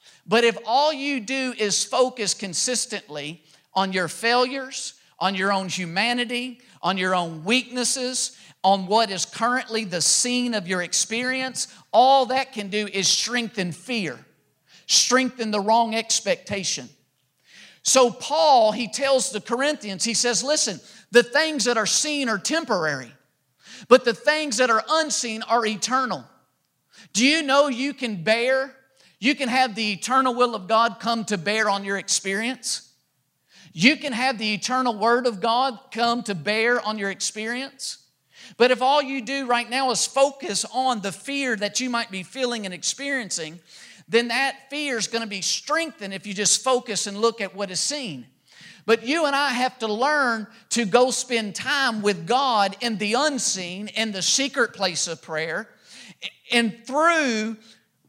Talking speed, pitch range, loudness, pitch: 165 wpm, 195-255 Hz, -22 LUFS, 230 Hz